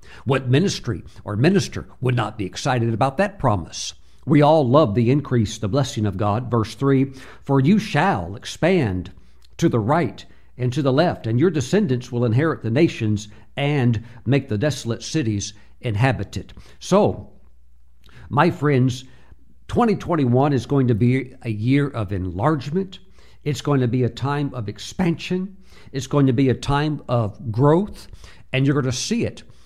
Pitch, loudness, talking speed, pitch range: 125 Hz, -21 LUFS, 160 wpm, 105-145 Hz